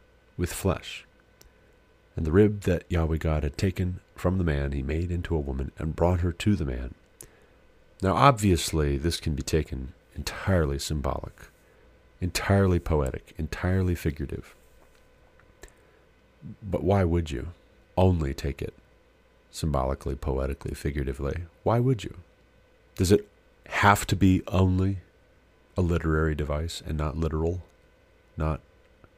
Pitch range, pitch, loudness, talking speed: 75-90 Hz, 85 Hz, -27 LUFS, 130 wpm